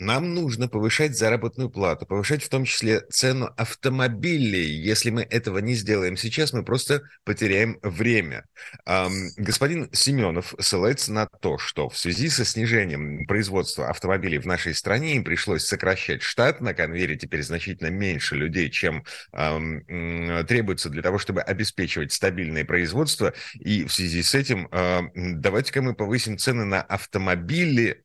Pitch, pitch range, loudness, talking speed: 110 Hz, 90-125 Hz, -24 LUFS, 145 wpm